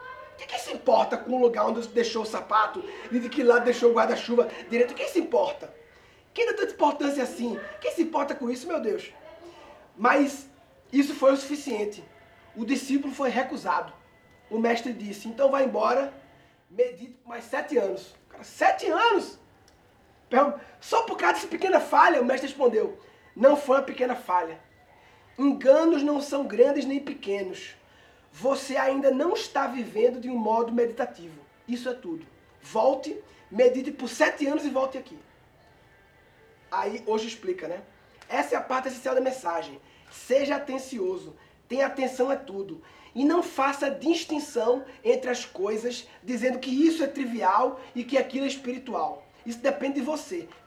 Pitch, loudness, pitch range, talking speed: 270 Hz, -26 LUFS, 245-295 Hz, 160 wpm